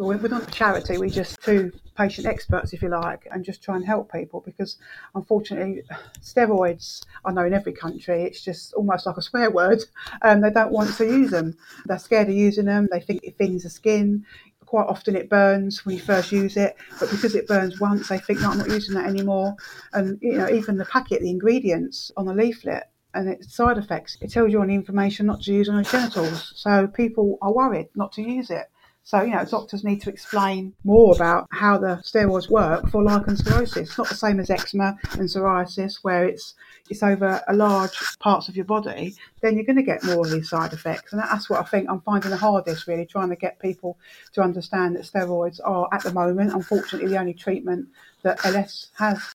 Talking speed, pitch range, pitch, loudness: 220 wpm, 185-210 Hz, 195 Hz, -22 LUFS